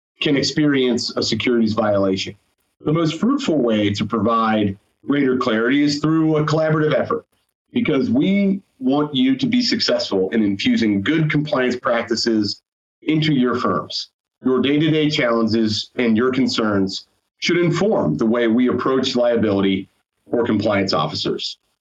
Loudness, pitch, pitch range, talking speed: -19 LUFS, 125 Hz, 110-155 Hz, 135 wpm